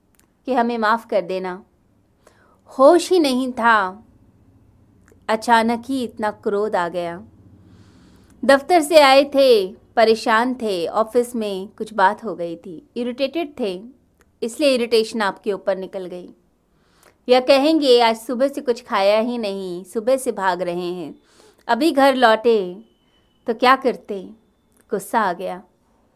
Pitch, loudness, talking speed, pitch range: 225 Hz, -18 LUFS, 135 wpm, 190-255 Hz